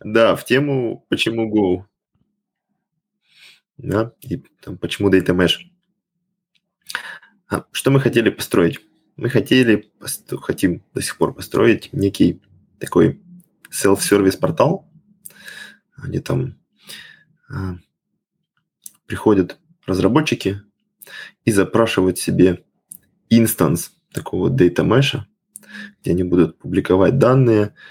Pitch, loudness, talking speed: 115 Hz, -18 LUFS, 95 wpm